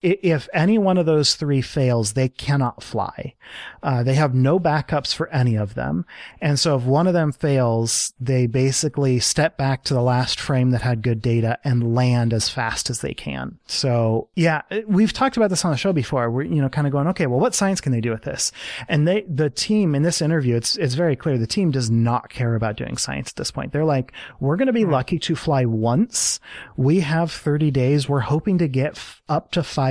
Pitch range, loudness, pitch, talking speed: 125-160 Hz, -20 LUFS, 140 Hz, 230 wpm